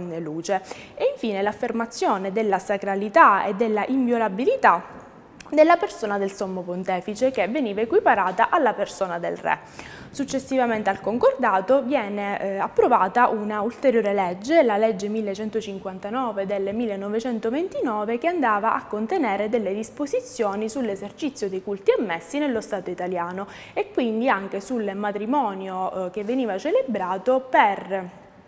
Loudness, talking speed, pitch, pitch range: -23 LUFS, 120 wpm, 215 Hz, 195-255 Hz